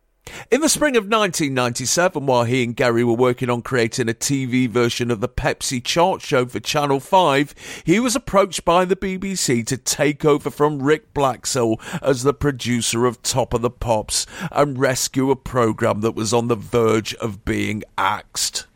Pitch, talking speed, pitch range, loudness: 130 Hz, 180 wpm, 120-150 Hz, -19 LUFS